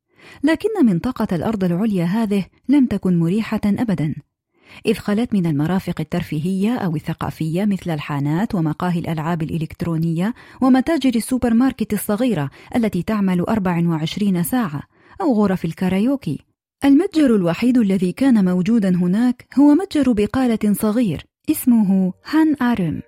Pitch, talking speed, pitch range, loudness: 205 Hz, 115 wpm, 175-245 Hz, -19 LUFS